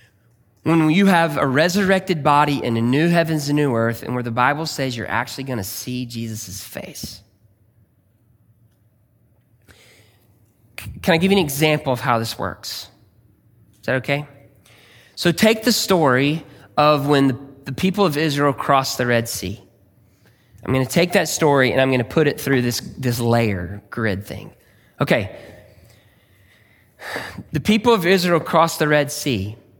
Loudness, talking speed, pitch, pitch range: -19 LUFS, 155 wpm, 125 Hz, 110-150 Hz